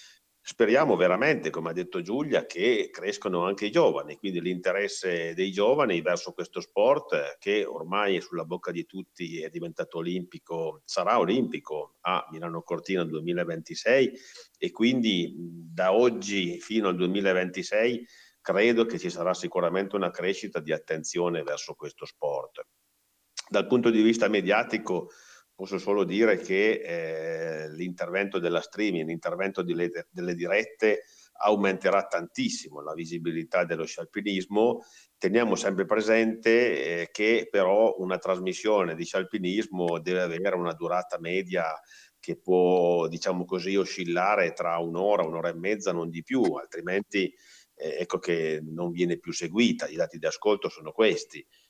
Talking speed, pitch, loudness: 140 wpm, 95 Hz, -27 LUFS